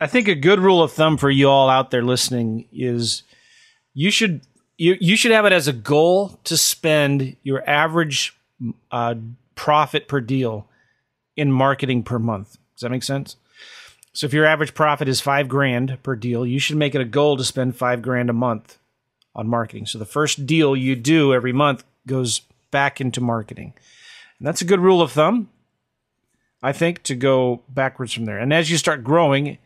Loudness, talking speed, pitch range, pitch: -19 LUFS, 190 wpm, 125-155 Hz, 135 Hz